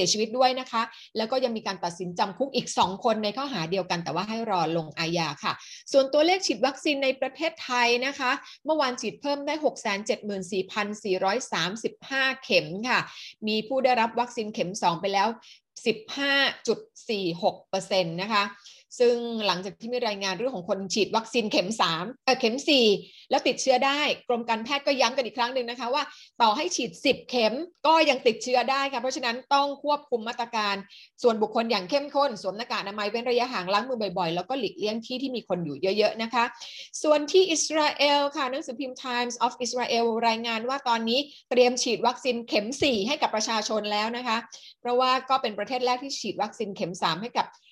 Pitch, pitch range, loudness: 235 Hz, 205-265 Hz, -26 LUFS